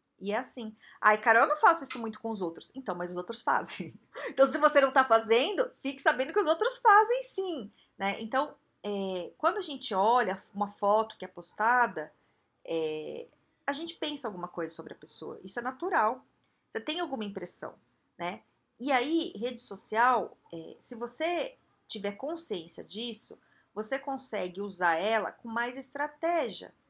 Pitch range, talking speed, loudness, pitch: 205-300 Hz, 170 wpm, -30 LUFS, 240 Hz